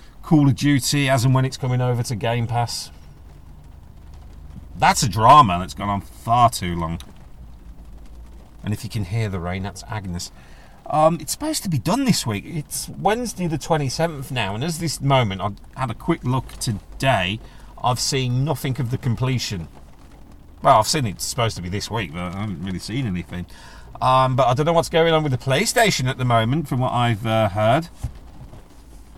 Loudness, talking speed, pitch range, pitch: -21 LUFS, 195 wpm, 90-135 Hz, 115 Hz